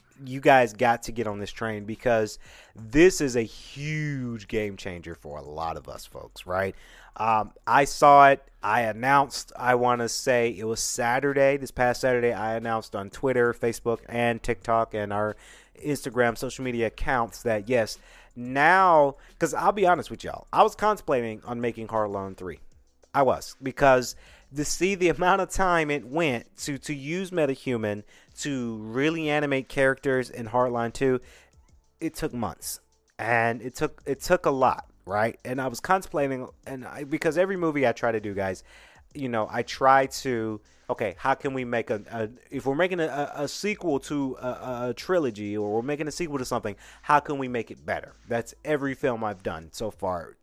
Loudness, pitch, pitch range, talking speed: -26 LUFS, 125 Hz, 115-145 Hz, 185 wpm